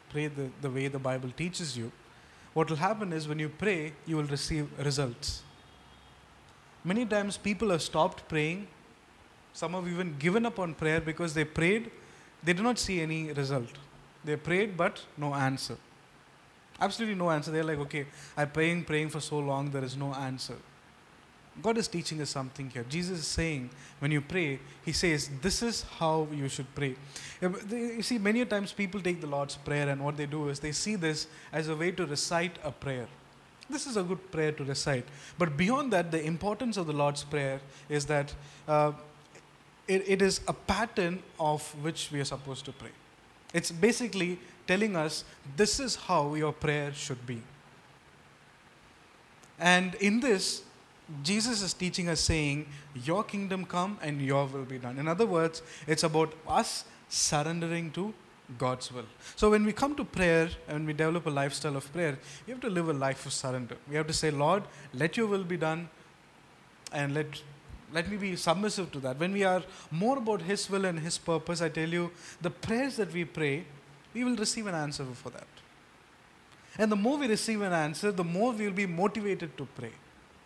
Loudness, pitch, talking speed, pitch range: -31 LUFS, 160 Hz, 190 wpm, 145-185 Hz